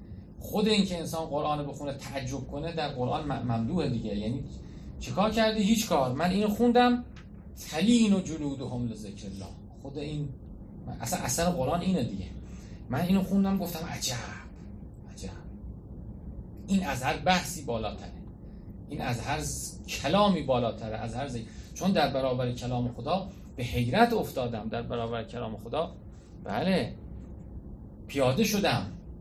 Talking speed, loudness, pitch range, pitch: 135 wpm, -29 LUFS, 115-180 Hz, 135 Hz